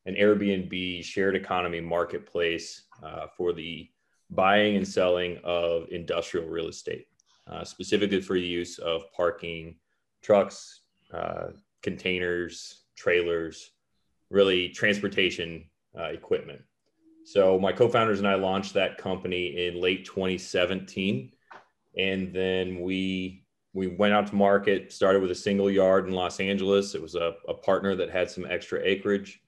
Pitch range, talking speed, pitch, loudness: 85-100 Hz, 140 wpm, 95 Hz, -27 LUFS